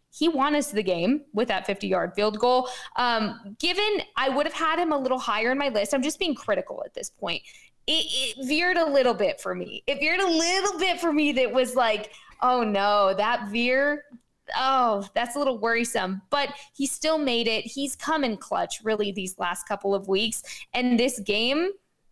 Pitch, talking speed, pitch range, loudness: 255 Hz, 205 wpm, 215-290 Hz, -25 LUFS